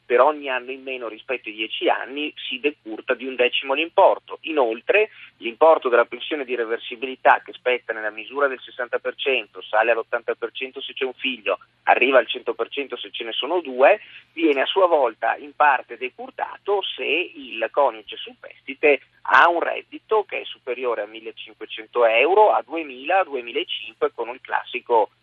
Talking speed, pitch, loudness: 160 wpm, 185 Hz, -22 LUFS